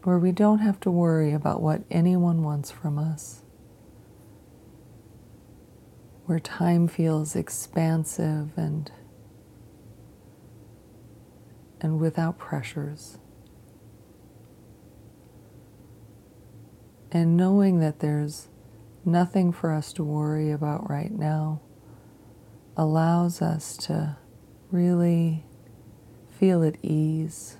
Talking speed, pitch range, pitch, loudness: 85 wpm, 115-170 Hz, 155 Hz, -25 LUFS